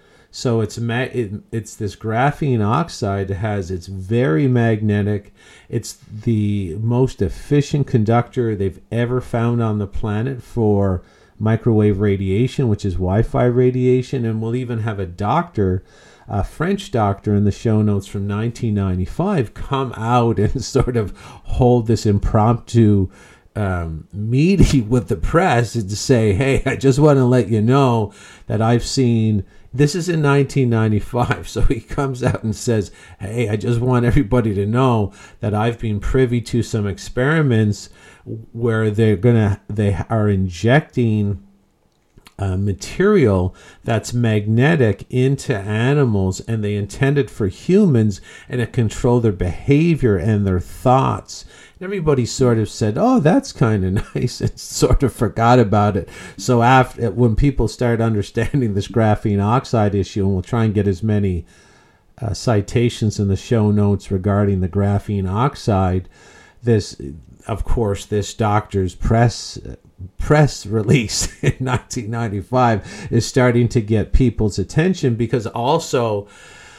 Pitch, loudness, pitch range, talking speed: 115 Hz, -18 LUFS, 100-125 Hz, 145 wpm